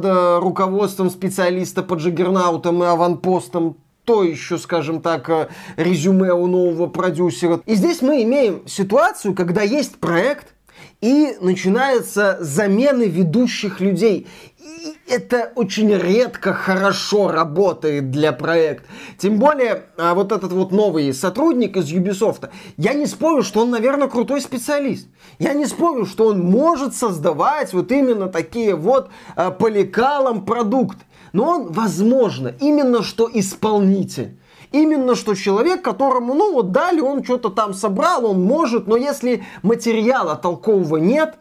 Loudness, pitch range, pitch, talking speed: -18 LUFS, 180-250 Hz, 205 Hz, 130 wpm